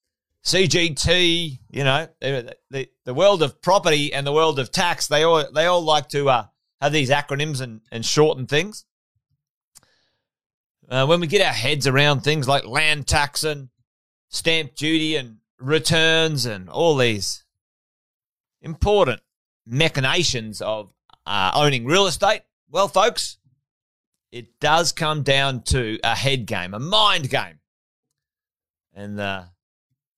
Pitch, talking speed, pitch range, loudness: 140 Hz, 135 wpm, 120-160 Hz, -20 LUFS